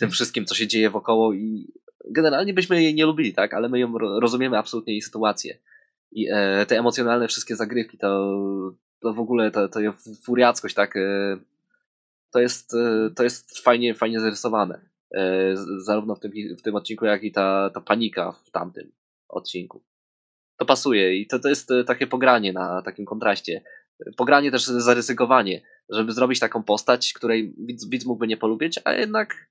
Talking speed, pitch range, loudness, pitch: 165 wpm, 105-125 Hz, -22 LUFS, 115 Hz